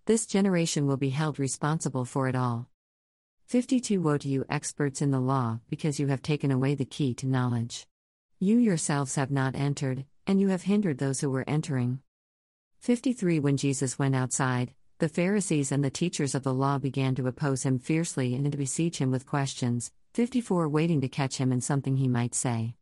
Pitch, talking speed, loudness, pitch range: 140 Hz, 195 wpm, -28 LUFS, 130-155 Hz